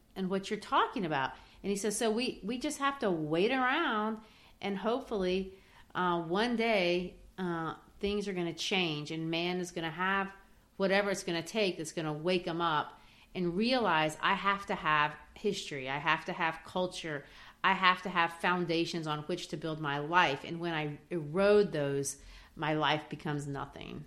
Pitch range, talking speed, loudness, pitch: 160-200 Hz, 190 wpm, -32 LUFS, 180 Hz